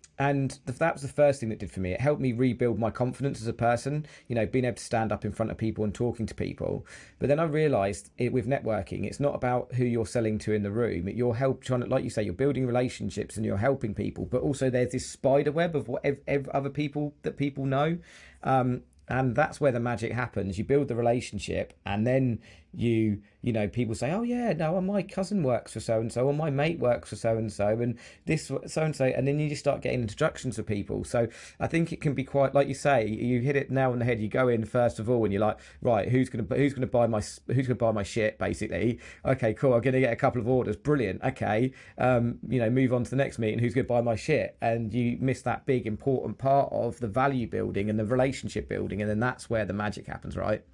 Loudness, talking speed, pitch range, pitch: -28 LUFS, 255 wpm, 110-135 Hz, 125 Hz